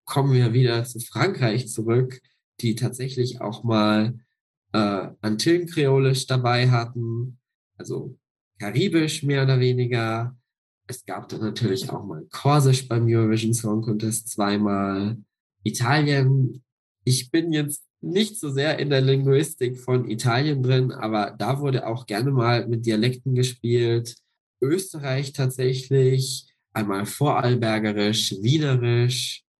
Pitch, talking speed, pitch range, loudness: 125 Hz, 120 wpm, 115-135 Hz, -23 LUFS